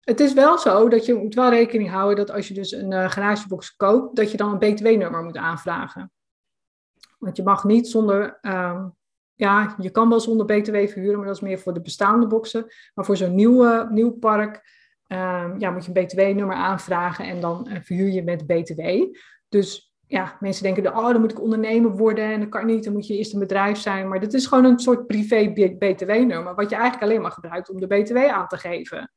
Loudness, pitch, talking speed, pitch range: -20 LUFS, 205 Hz, 220 wpm, 190-225 Hz